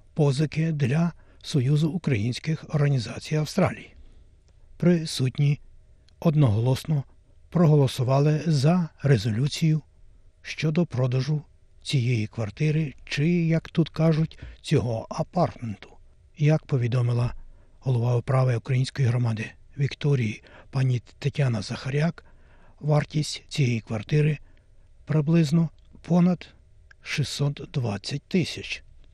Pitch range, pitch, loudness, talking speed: 115-155 Hz, 140 Hz, -25 LUFS, 80 wpm